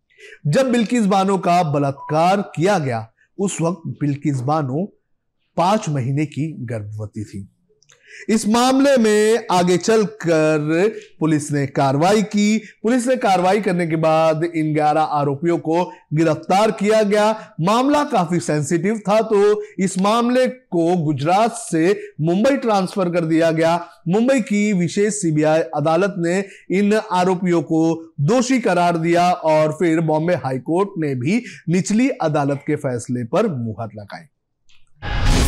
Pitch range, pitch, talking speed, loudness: 155-210 Hz, 175 Hz, 130 wpm, -18 LUFS